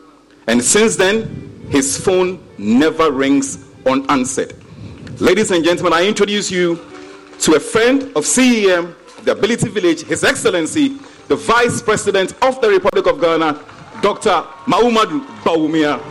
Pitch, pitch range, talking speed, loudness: 185 Hz, 155-240 Hz, 130 wpm, -15 LUFS